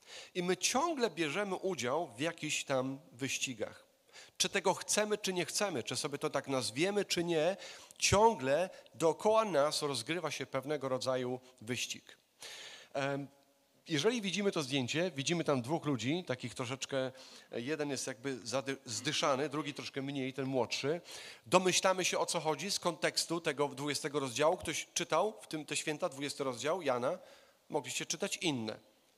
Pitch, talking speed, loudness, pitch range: 150 Hz, 145 wpm, -35 LUFS, 135-180 Hz